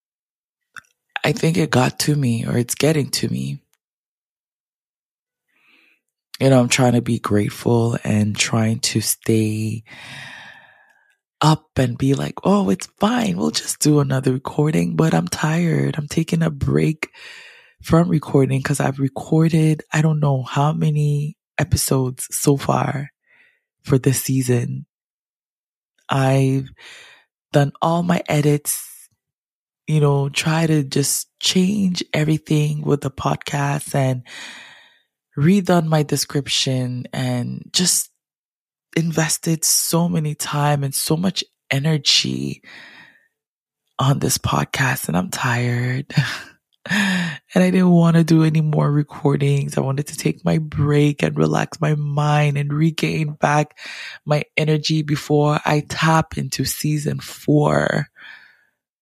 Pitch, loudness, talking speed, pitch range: 145 Hz, -19 LUFS, 125 wpm, 130-160 Hz